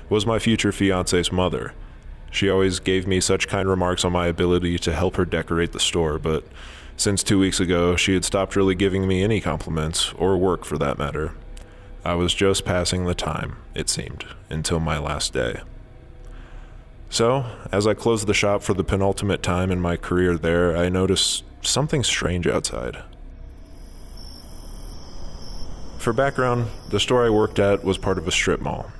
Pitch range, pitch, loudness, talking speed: 80-100 Hz, 90 Hz, -22 LUFS, 170 wpm